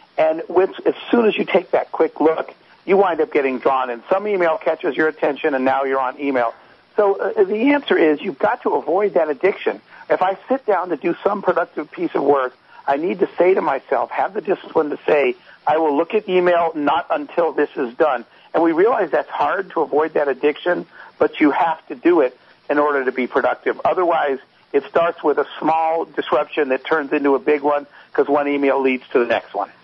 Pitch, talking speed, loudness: 160 Hz, 220 wpm, -19 LUFS